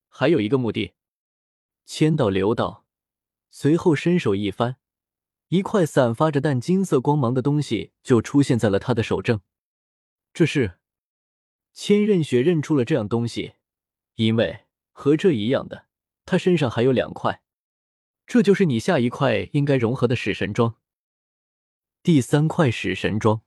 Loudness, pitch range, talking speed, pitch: -21 LUFS, 110-155 Hz, 215 characters per minute, 125 Hz